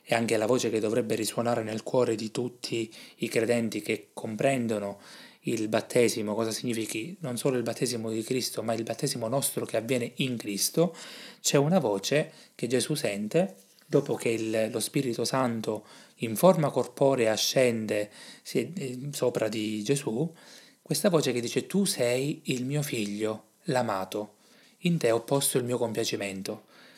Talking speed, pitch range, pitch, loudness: 155 wpm, 110-140 Hz, 120 Hz, -28 LUFS